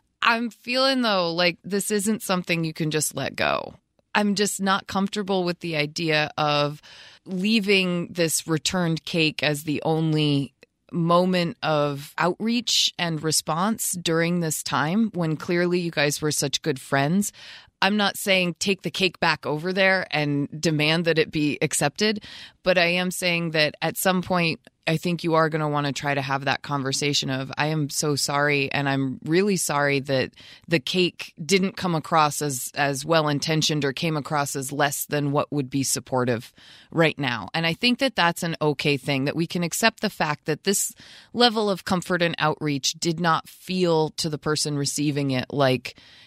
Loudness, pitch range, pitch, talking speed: -23 LUFS, 145-180 Hz, 160 Hz, 180 wpm